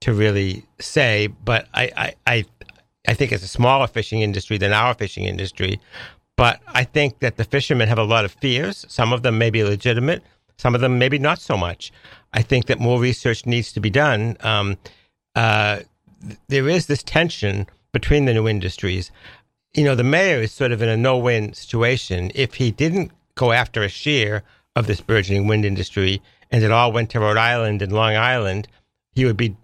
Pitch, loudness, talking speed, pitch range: 115 Hz, -19 LUFS, 200 wpm, 105-125 Hz